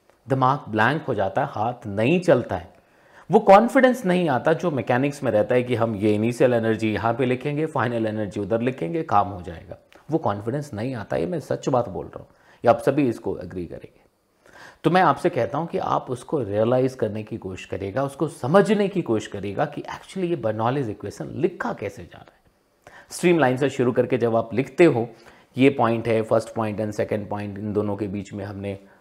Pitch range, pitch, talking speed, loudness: 110-150 Hz, 125 Hz, 210 wpm, -22 LUFS